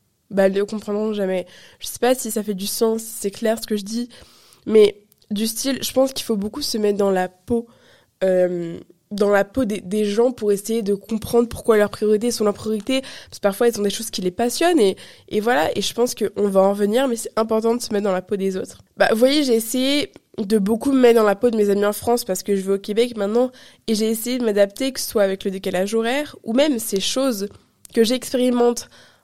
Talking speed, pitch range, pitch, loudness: 250 wpm, 205-240 Hz, 220 Hz, -20 LUFS